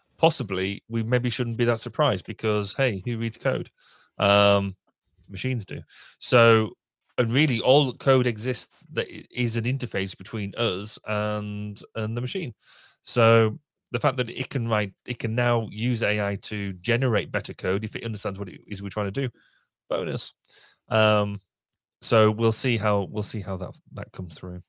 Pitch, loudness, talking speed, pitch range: 110 Hz, -25 LUFS, 170 wpm, 100-125 Hz